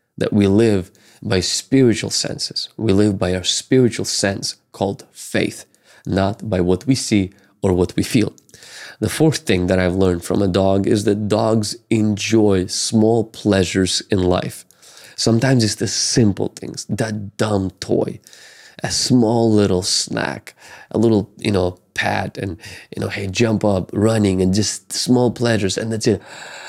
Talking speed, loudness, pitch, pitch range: 160 wpm, -18 LUFS, 105 Hz, 95-110 Hz